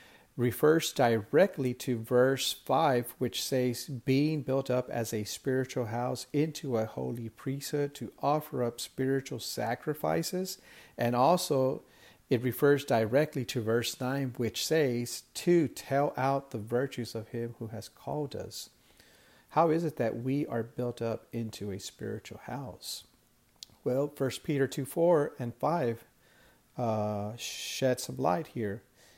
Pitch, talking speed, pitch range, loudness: 125 Hz, 140 wpm, 115-140 Hz, -31 LUFS